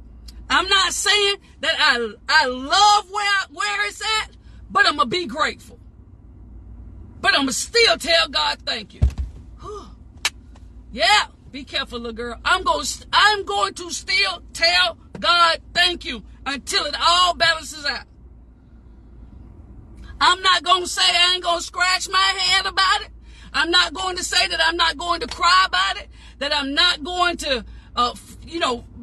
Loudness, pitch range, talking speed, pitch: -18 LUFS, 325-385 Hz, 160 wpm, 355 Hz